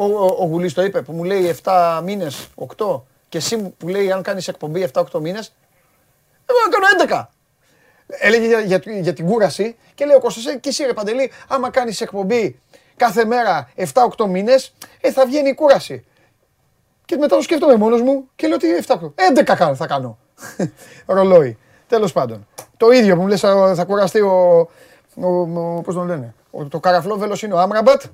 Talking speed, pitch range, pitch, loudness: 170 wpm, 180-255 Hz, 200 Hz, -16 LUFS